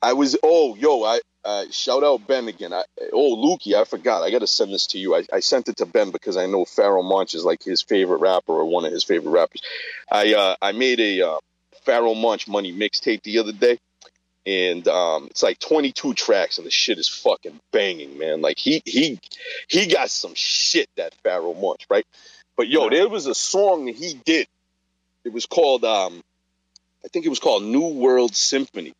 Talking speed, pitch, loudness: 210 wpm, 355 Hz, -20 LUFS